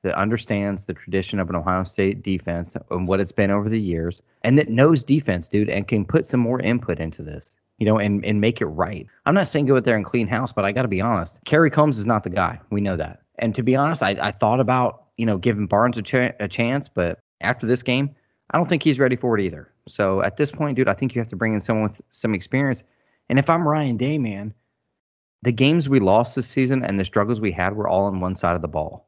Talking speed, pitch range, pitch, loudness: 265 wpm, 100-130 Hz, 110 Hz, -21 LUFS